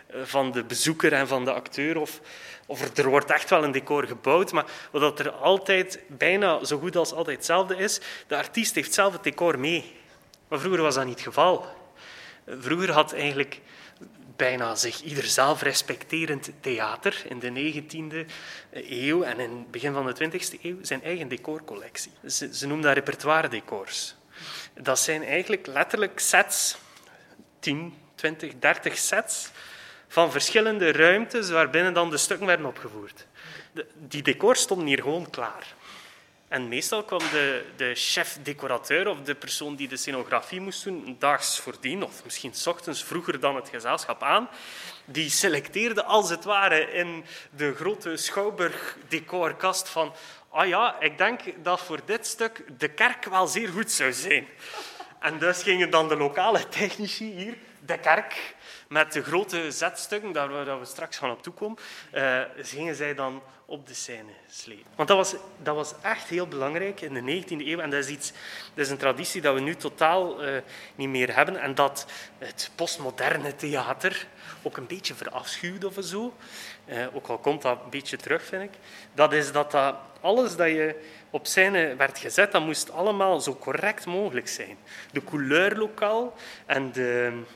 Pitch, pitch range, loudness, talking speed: 160 Hz, 140-190 Hz, -26 LUFS, 170 wpm